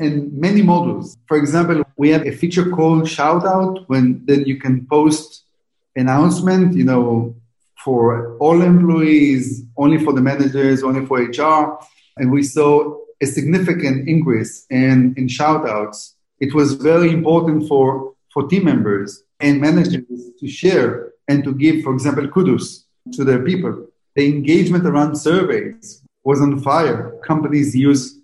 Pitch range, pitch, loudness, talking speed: 135-160 Hz, 145 Hz, -16 LUFS, 145 wpm